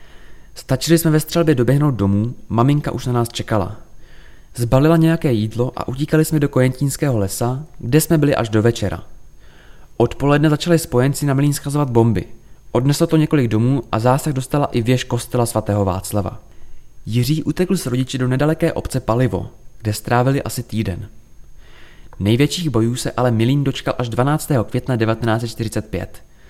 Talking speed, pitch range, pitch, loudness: 150 wpm, 110-145 Hz, 125 Hz, -18 LUFS